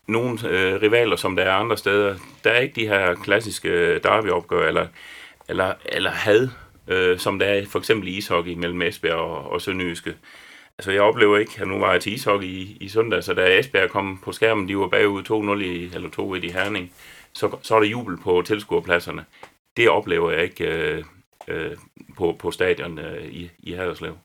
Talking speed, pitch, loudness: 200 wpm, 110 Hz, -21 LUFS